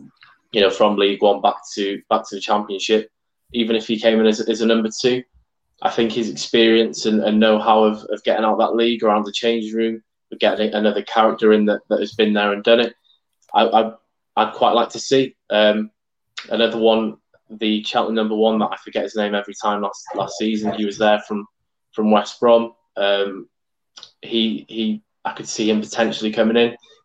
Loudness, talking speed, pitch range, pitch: -19 LUFS, 205 wpm, 105-115 Hz, 110 Hz